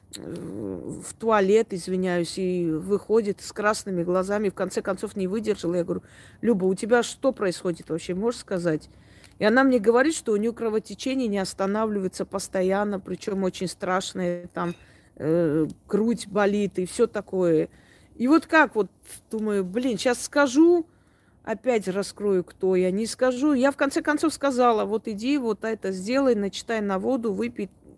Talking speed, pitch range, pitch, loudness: 155 wpm, 185-235 Hz, 205 Hz, -25 LUFS